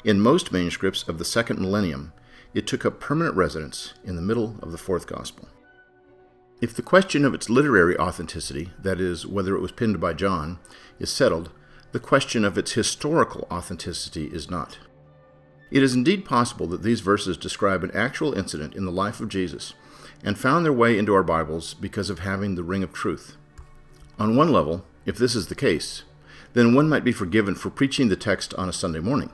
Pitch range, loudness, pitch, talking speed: 85-120 Hz, -23 LUFS, 95 Hz, 195 wpm